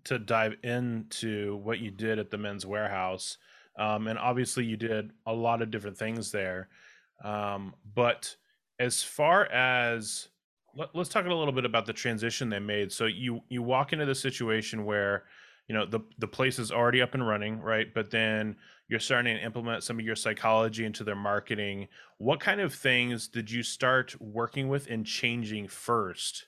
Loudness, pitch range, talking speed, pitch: -30 LUFS, 105-120 Hz, 185 wpm, 115 Hz